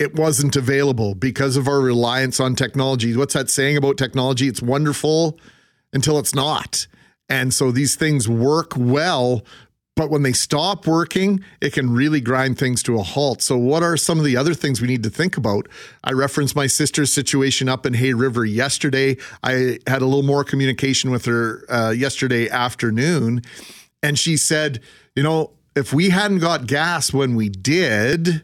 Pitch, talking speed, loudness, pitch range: 135 Hz, 180 wpm, -19 LUFS, 125-150 Hz